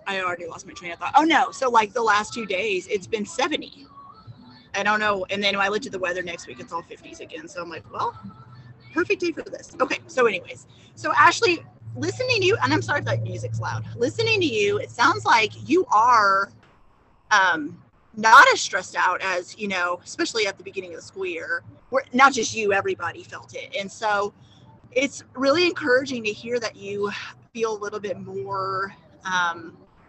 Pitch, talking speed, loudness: 210 Hz, 205 wpm, -22 LUFS